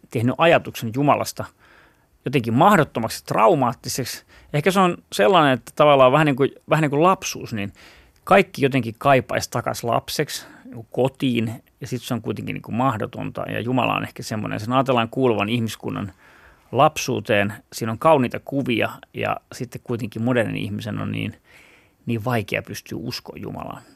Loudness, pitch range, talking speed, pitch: -21 LUFS, 115-140 Hz, 155 wpm, 125 Hz